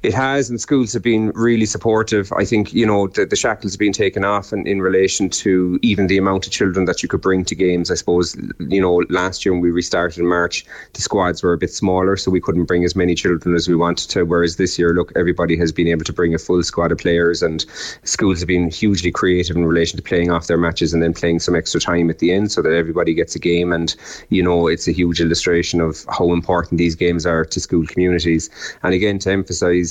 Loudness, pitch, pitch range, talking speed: -17 LUFS, 90 Hz, 85-95 Hz, 250 wpm